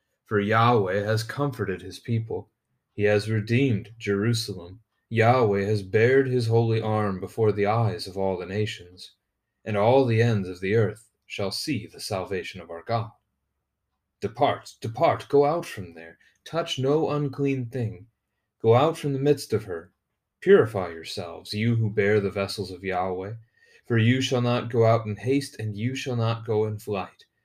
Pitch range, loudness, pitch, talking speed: 100-120 Hz, -25 LUFS, 110 Hz, 170 wpm